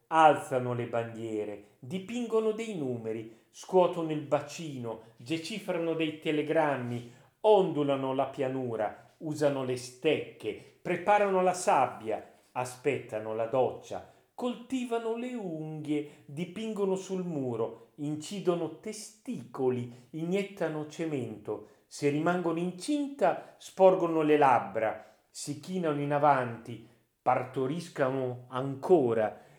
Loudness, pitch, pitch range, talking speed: -31 LUFS, 150 Hz, 125-180 Hz, 95 wpm